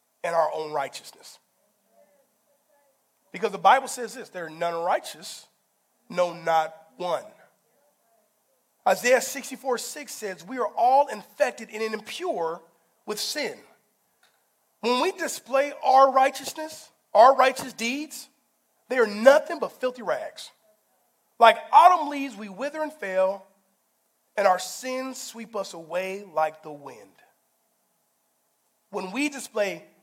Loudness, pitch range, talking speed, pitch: -24 LUFS, 190-280 Hz, 120 wpm, 240 Hz